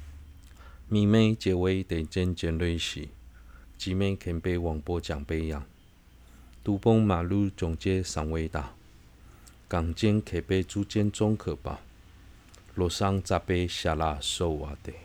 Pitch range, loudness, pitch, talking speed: 80-95 Hz, -29 LUFS, 85 Hz, 185 characters per minute